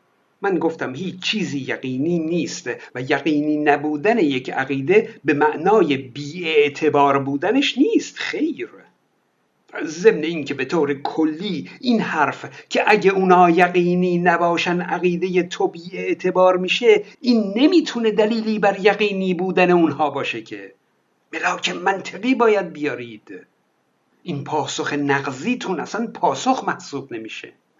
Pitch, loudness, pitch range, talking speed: 180 Hz, -19 LUFS, 150-210 Hz, 120 wpm